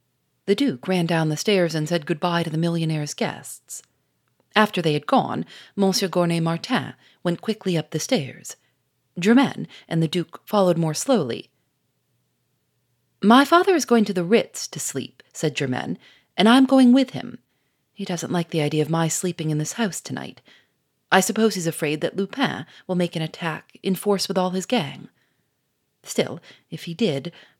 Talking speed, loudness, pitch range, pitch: 175 wpm, -22 LUFS, 160-205 Hz, 175 Hz